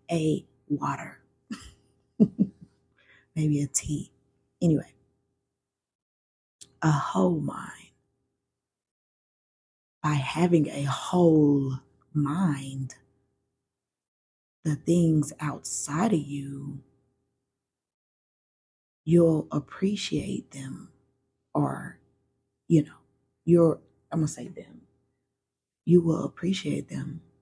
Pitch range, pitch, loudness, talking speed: 130-155 Hz, 140 Hz, -27 LUFS, 75 wpm